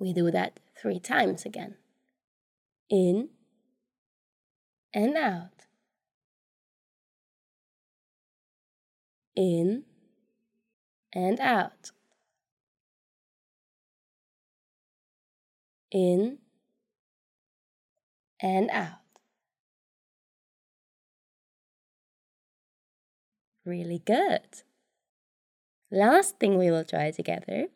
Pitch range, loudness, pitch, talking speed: 185-230 Hz, -27 LUFS, 215 Hz, 50 wpm